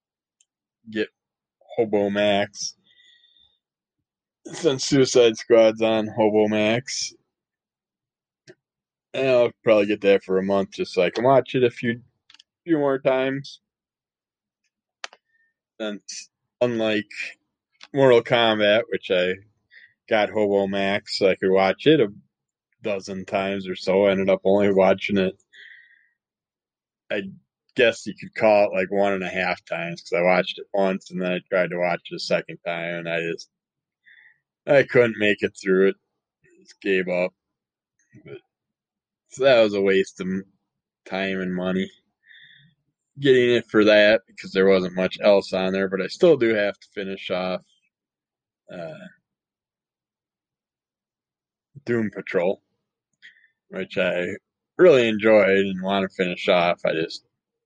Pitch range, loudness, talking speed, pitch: 95-115 Hz, -21 LUFS, 140 wpm, 100 Hz